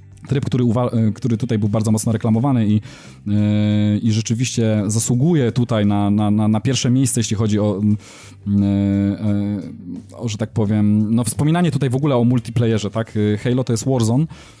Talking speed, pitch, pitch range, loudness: 175 wpm, 110 Hz, 105-125 Hz, -18 LUFS